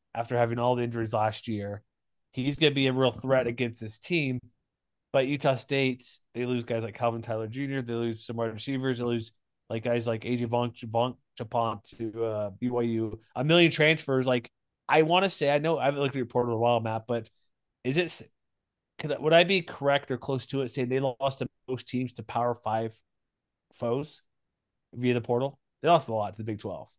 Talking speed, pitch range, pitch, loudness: 210 wpm, 115-135 Hz, 125 Hz, -28 LUFS